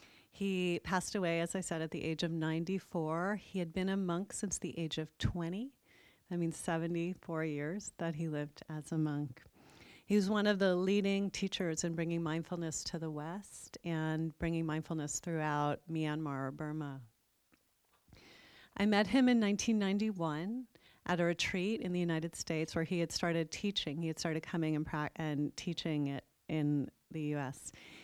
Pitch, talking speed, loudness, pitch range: 165 Hz, 170 wpm, -37 LUFS, 155-190 Hz